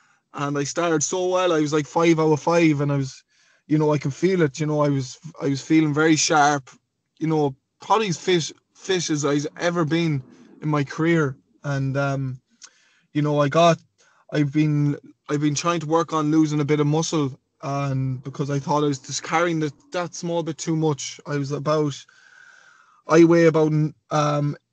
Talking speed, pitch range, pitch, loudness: 200 wpm, 145-165 Hz, 155 Hz, -22 LUFS